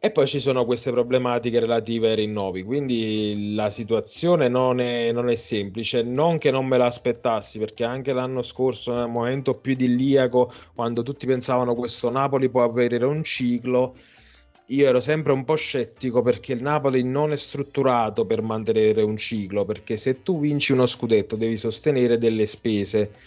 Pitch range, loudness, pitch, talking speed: 115-130 Hz, -23 LUFS, 125 Hz, 170 wpm